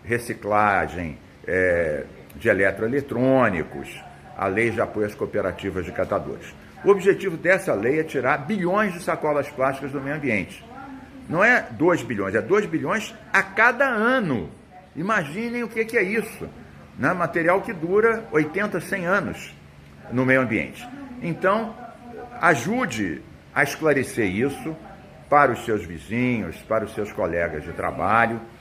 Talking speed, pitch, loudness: 135 wpm, 165 Hz, -22 LUFS